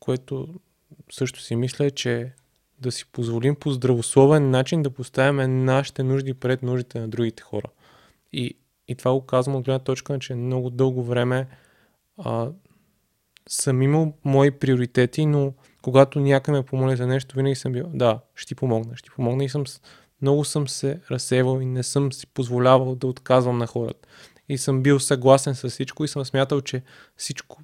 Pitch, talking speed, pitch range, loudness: 130 Hz, 175 wpm, 125-140 Hz, -23 LUFS